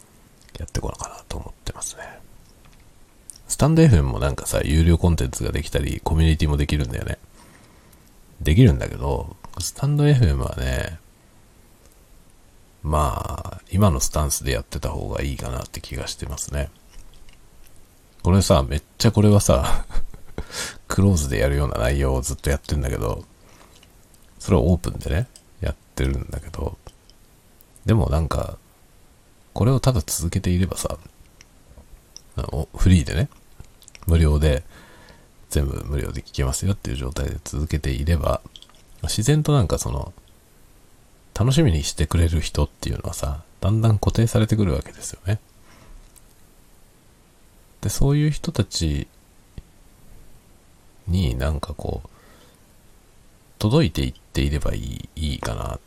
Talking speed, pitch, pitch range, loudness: 285 characters per minute, 90 Hz, 75-105 Hz, -22 LUFS